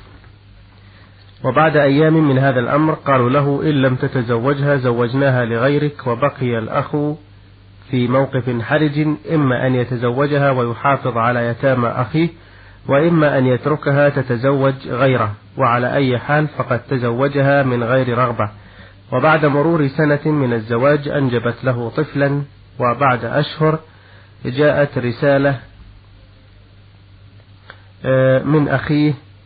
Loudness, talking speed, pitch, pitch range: -16 LUFS, 105 wpm, 130 Hz, 115-145 Hz